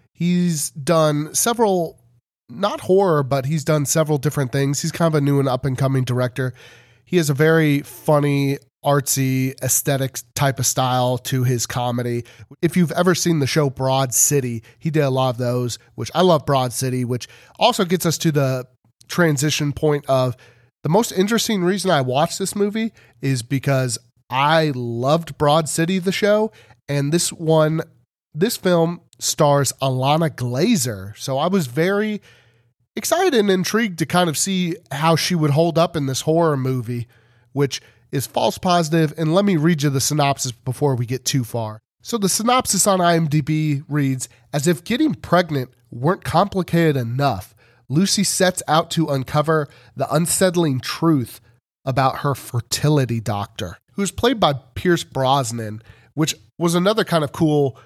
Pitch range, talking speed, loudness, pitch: 125-170 Hz, 165 wpm, -19 LUFS, 145 Hz